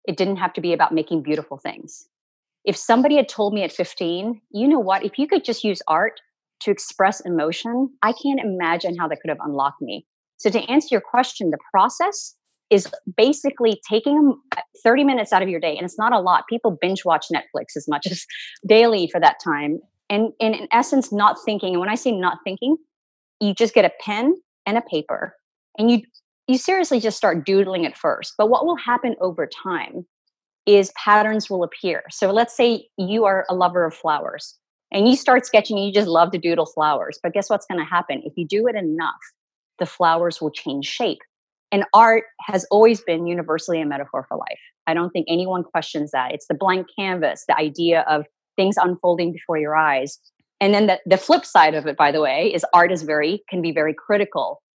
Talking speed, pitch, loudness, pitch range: 210 wpm, 195 Hz, -20 LUFS, 170-230 Hz